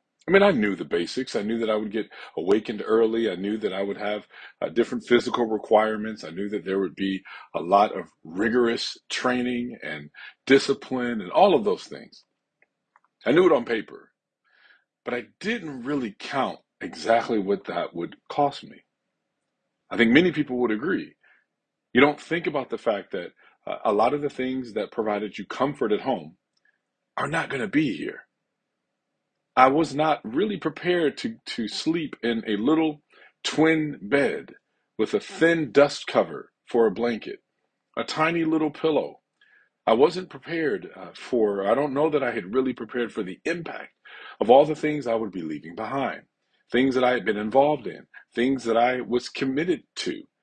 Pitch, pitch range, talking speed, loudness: 130 Hz, 110-155 Hz, 180 wpm, -24 LUFS